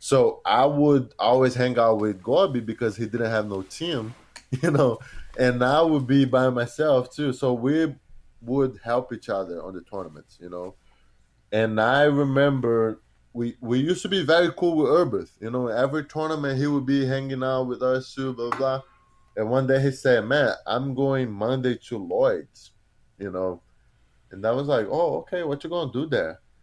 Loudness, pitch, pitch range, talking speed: -24 LUFS, 130 Hz, 115-140 Hz, 190 wpm